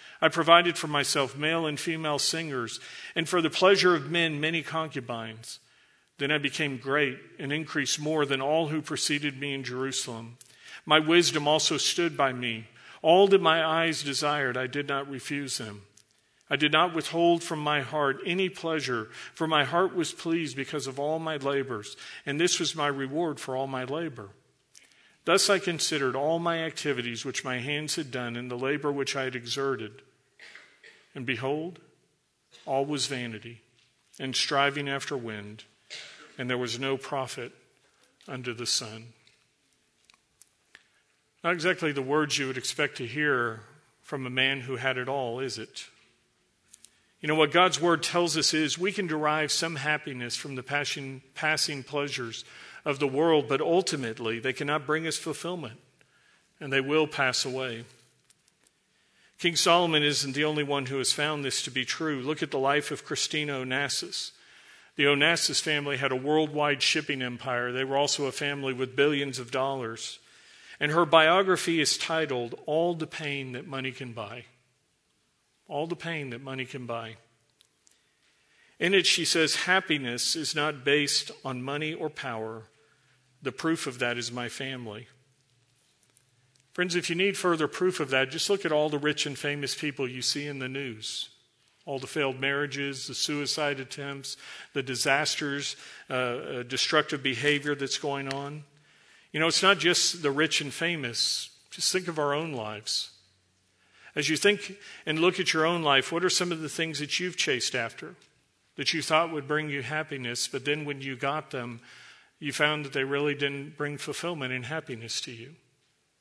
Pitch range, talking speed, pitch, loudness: 130-155 Hz, 170 wpm, 145 Hz, -27 LUFS